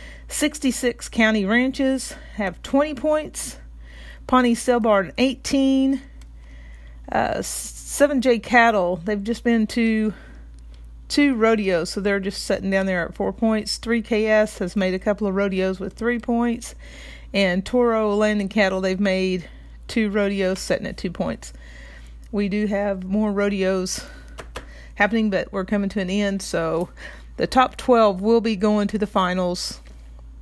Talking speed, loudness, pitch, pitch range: 140 wpm, -21 LUFS, 205 Hz, 185-230 Hz